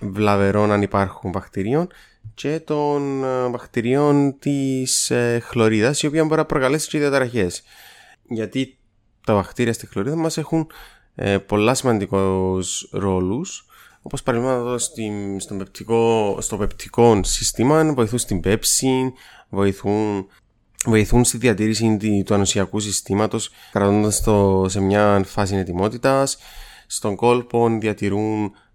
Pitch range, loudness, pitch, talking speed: 100-130 Hz, -20 LUFS, 110 Hz, 110 wpm